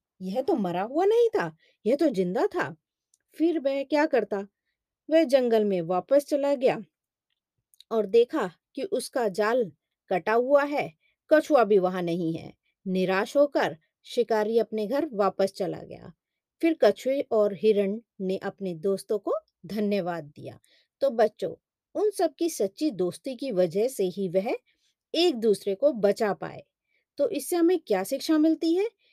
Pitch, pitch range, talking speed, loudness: 220 Hz, 195-295 Hz, 155 wpm, -26 LUFS